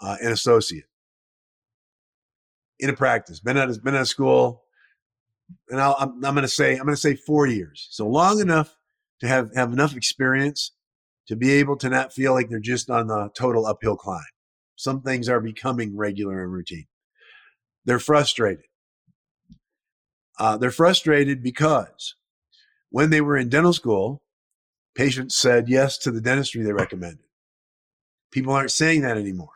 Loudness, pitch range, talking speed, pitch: -21 LUFS, 110-140 Hz, 160 wpm, 130 Hz